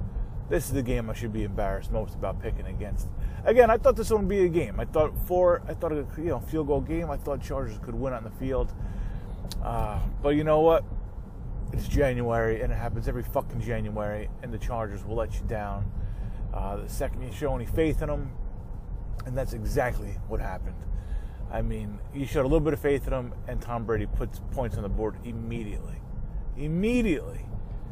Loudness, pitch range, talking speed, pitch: -29 LUFS, 100-135 Hz, 205 wpm, 115 Hz